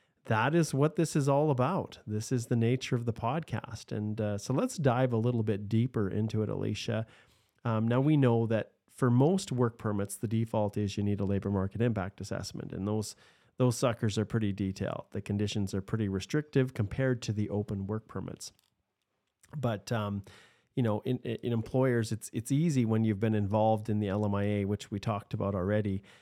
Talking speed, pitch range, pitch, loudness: 195 wpm, 105-125 Hz, 110 Hz, -31 LUFS